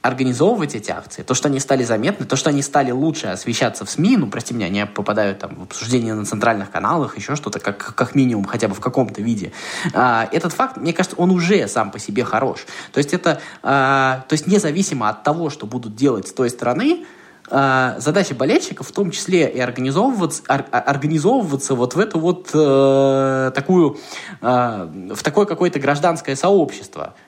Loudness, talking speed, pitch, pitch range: -18 LUFS, 175 wpm, 135 Hz, 120-160 Hz